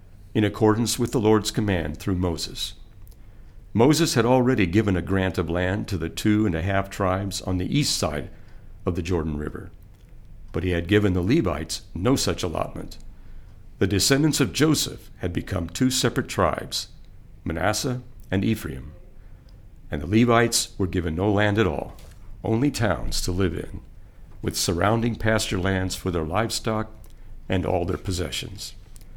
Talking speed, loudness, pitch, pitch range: 160 wpm, -24 LUFS, 100 Hz, 90-110 Hz